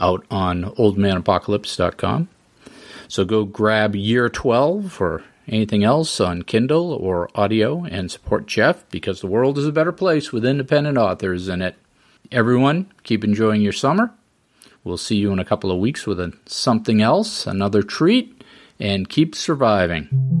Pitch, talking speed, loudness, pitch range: 110 Hz, 155 wpm, -19 LUFS, 100-145 Hz